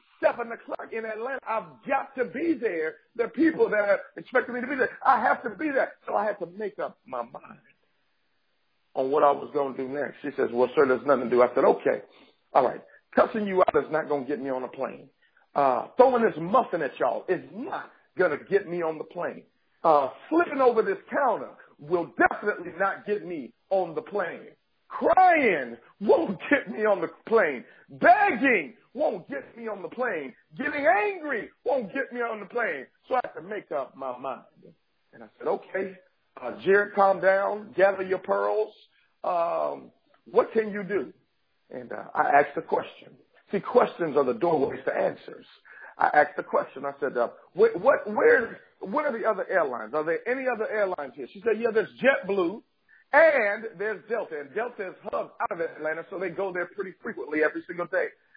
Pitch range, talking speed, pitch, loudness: 175-265 Hz, 205 wpm, 210 Hz, -26 LUFS